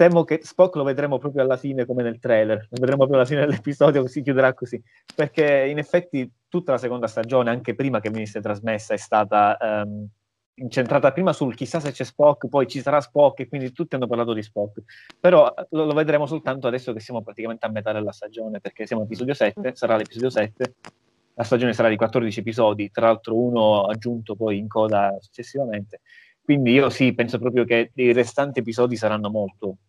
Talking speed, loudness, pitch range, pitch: 200 wpm, -22 LUFS, 110-140 Hz, 125 Hz